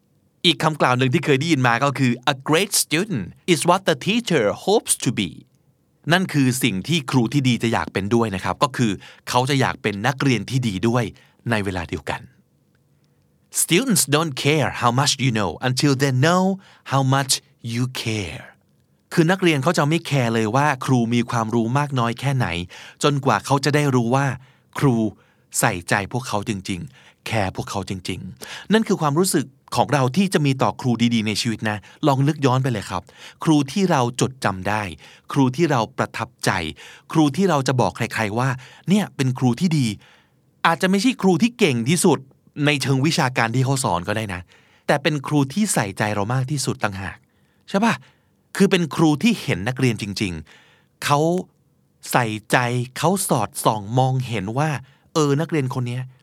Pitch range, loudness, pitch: 115-155 Hz, -20 LUFS, 130 Hz